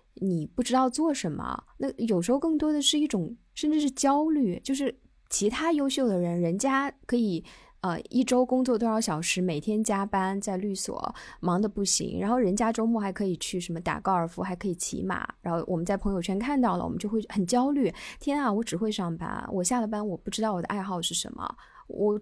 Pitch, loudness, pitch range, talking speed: 215 Hz, -28 LUFS, 185-255 Hz, 315 characters per minute